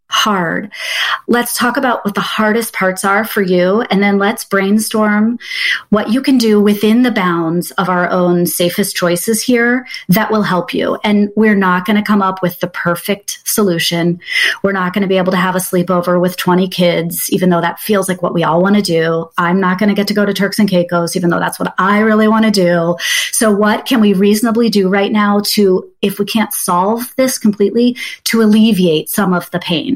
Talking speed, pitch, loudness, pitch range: 215 wpm, 200 Hz, -13 LUFS, 180-215 Hz